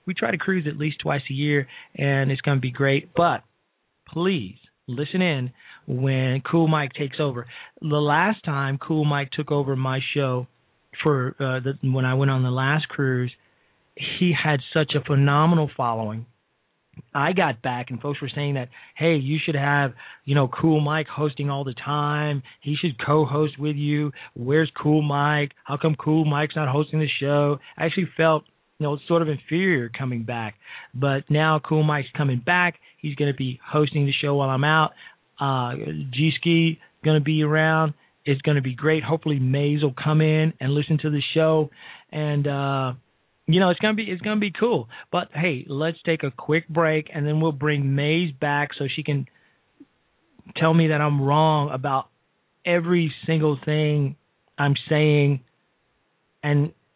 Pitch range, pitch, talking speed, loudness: 140-155 Hz, 150 Hz, 180 wpm, -23 LUFS